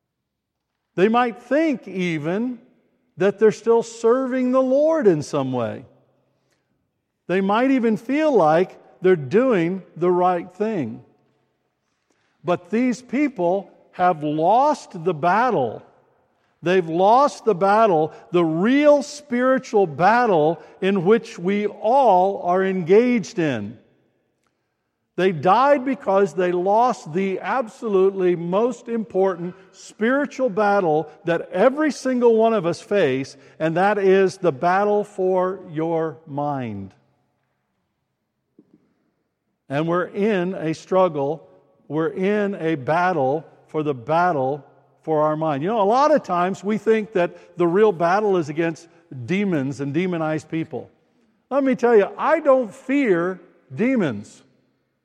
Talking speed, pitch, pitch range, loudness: 120 wpm, 190 Hz, 165-225 Hz, -20 LUFS